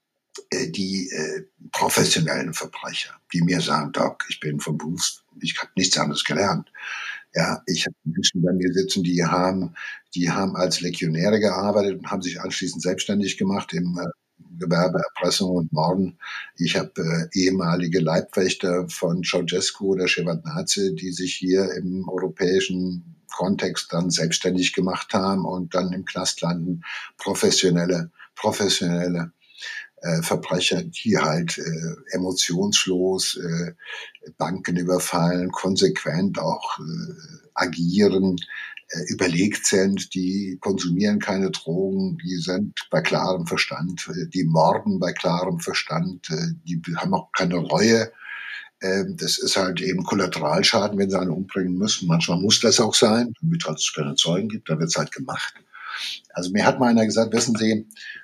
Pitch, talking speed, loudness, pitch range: 90 Hz, 140 wpm, -23 LUFS, 90-100 Hz